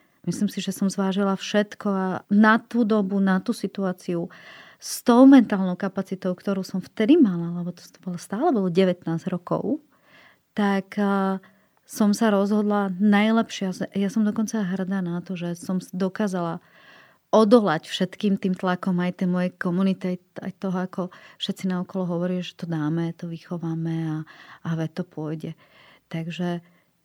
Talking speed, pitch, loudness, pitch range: 150 wpm, 190 Hz, -24 LUFS, 180-205 Hz